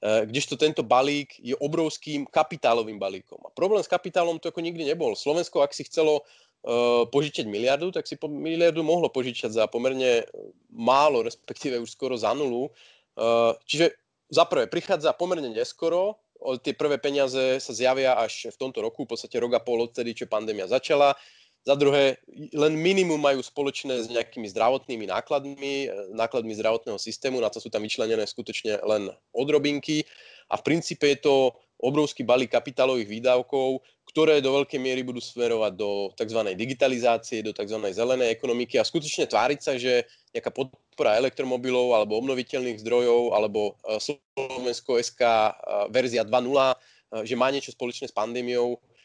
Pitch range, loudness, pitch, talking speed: 120-150 Hz, -25 LUFS, 130 Hz, 150 wpm